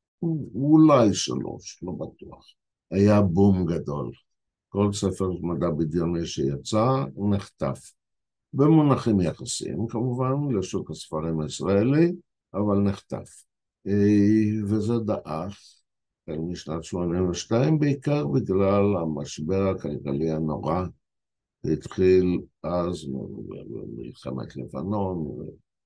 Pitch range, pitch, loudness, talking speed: 85-110 Hz, 100 Hz, -24 LUFS, 85 wpm